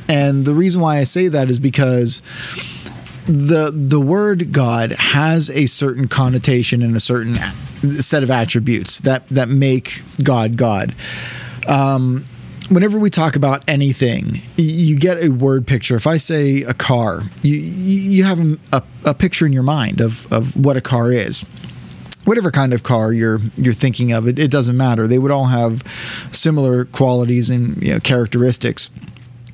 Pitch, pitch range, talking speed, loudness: 135 Hz, 120-150 Hz, 165 wpm, -15 LUFS